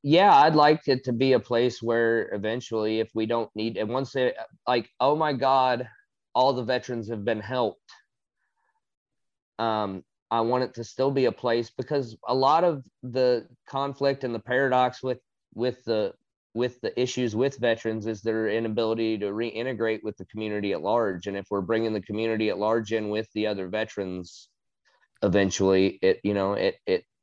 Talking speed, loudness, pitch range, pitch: 180 wpm, -26 LUFS, 110-130 Hz, 115 Hz